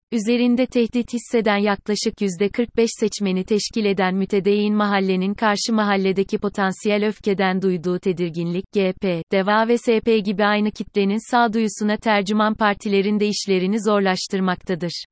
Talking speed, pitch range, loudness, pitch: 115 wpm, 195-220 Hz, -20 LUFS, 205 Hz